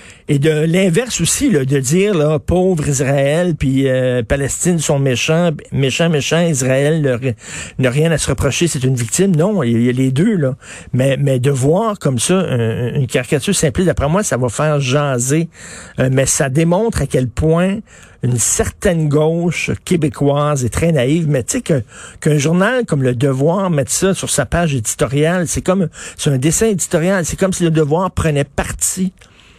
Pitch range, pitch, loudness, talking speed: 135-175 Hz, 150 Hz, -15 LUFS, 185 wpm